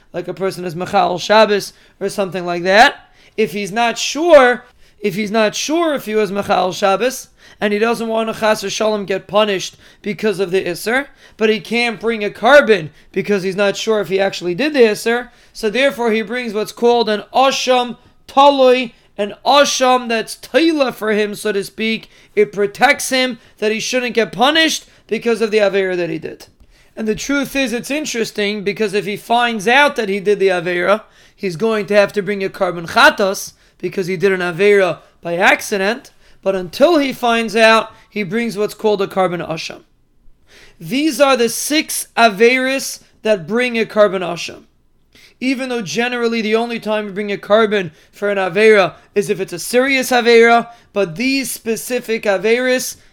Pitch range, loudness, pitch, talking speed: 200-240 Hz, -15 LUFS, 215 Hz, 185 wpm